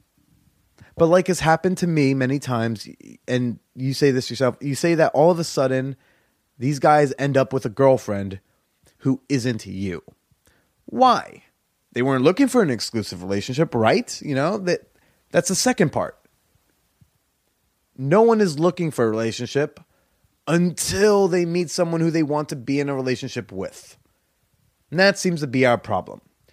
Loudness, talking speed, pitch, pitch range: -21 LUFS, 165 wpm, 140 Hz, 125-170 Hz